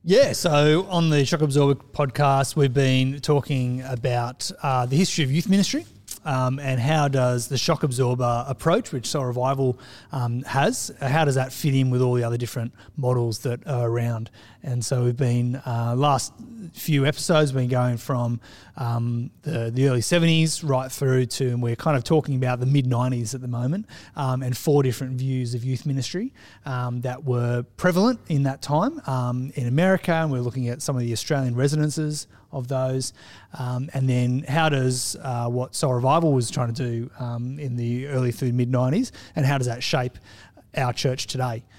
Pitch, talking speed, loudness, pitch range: 130 Hz, 190 wpm, -23 LUFS, 125-145 Hz